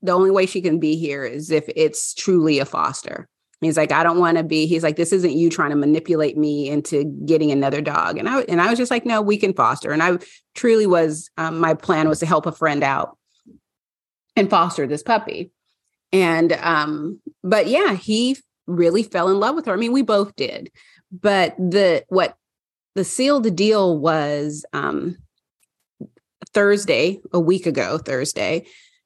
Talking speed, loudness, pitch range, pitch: 185 wpm, -19 LUFS, 155-205 Hz, 175 Hz